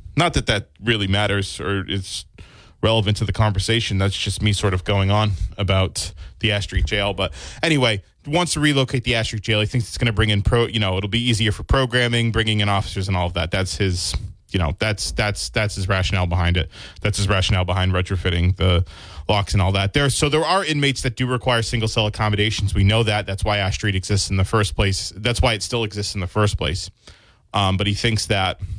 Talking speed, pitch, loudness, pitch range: 235 wpm, 100 Hz, -20 LUFS, 95-110 Hz